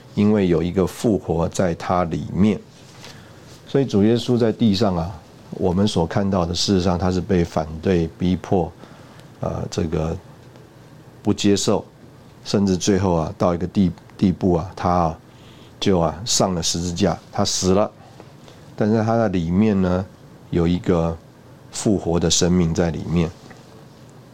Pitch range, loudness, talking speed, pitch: 90-120 Hz, -20 LUFS, 205 characters per minute, 100 Hz